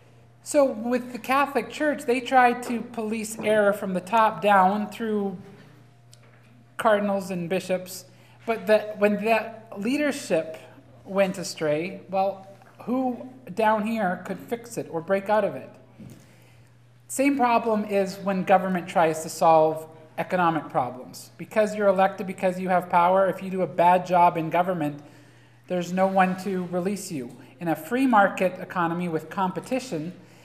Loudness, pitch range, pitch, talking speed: -24 LUFS, 165-215 Hz, 190 Hz, 150 wpm